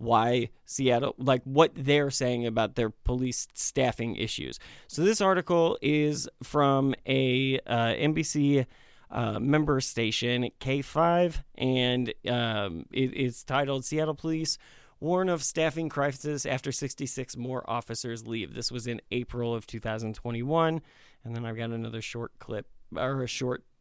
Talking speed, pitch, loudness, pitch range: 135 wpm, 130 Hz, -28 LUFS, 120-145 Hz